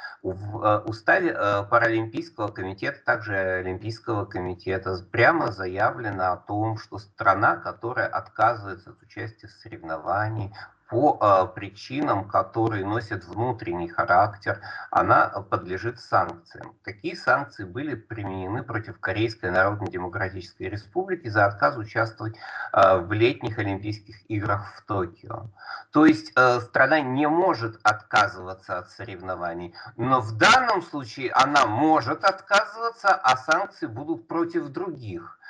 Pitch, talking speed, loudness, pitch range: 110 Hz, 110 wpm, -24 LUFS, 95-120 Hz